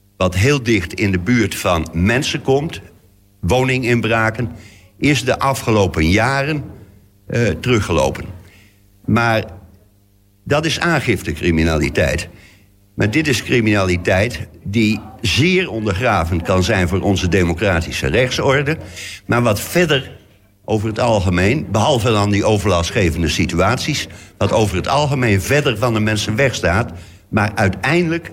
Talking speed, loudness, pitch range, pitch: 115 wpm, -16 LUFS, 95-120 Hz, 105 Hz